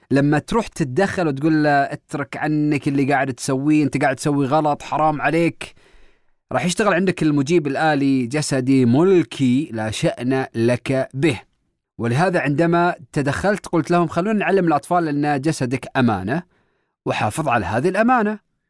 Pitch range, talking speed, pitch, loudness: 135-170 Hz, 135 wpm, 150 Hz, -19 LUFS